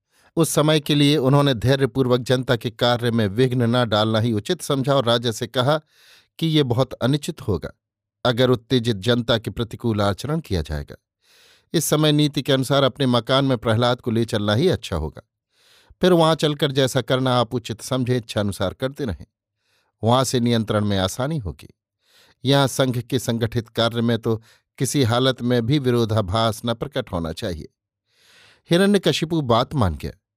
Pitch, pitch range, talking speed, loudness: 125 Hz, 115-140 Hz, 170 wpm, -21 LUFS